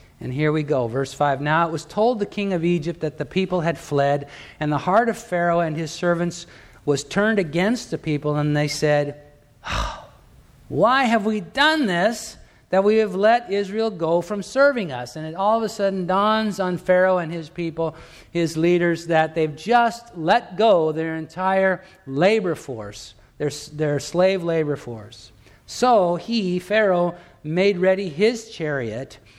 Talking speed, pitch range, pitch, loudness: 170 wpm, 150-200 Hz, 170 Hz, -21 LUFS